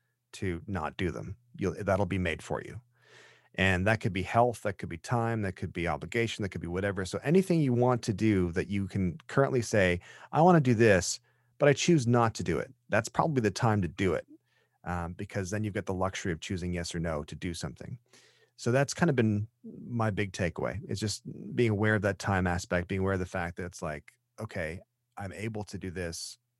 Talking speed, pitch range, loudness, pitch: 230 wpm, 90-120 Hz, -30 LUFS, 100 Hz